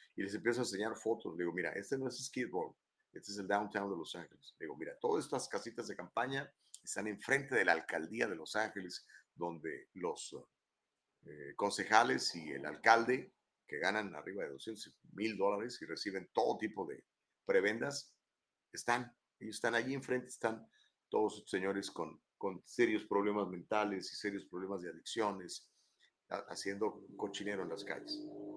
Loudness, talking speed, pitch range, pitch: -38 LUFS, 170 wpm, 95-120 Hz, 105 Hz